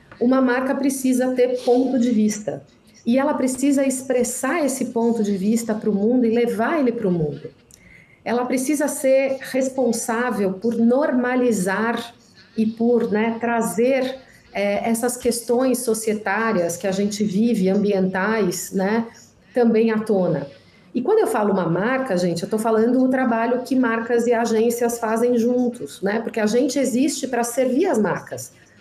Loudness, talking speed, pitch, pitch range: -20 LUFS, 155 wpm, 235 Hz, 215-255 Hz